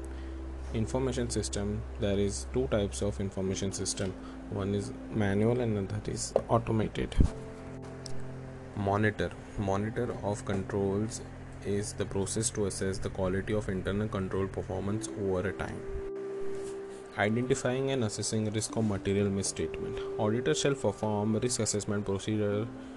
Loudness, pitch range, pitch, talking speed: -32 LUFS, 95-115 Hz, 105 Hz, 125 wpm